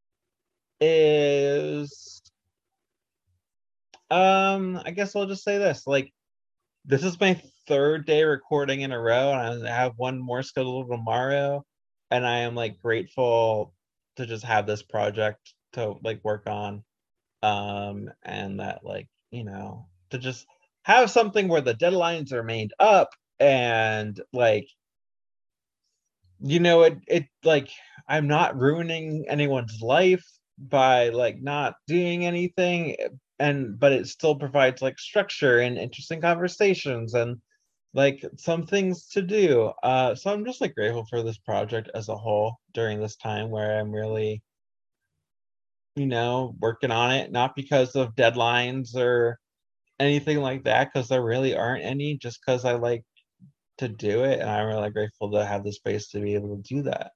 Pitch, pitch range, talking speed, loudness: 130 Hz, 110-150 Hz, 150 wpm, -24 LUFS